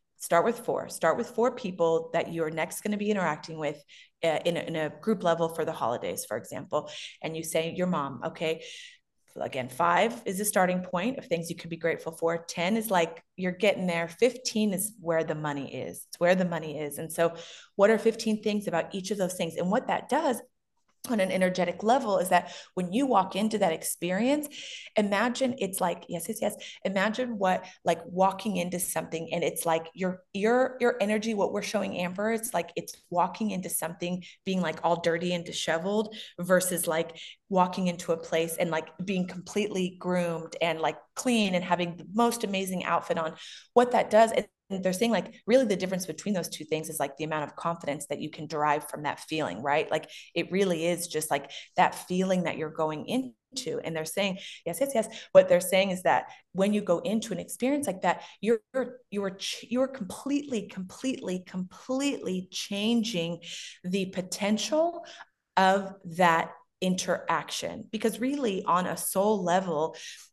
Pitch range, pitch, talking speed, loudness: 170-215 Hz, 185 Hz, 195 wpm, -29 LUFS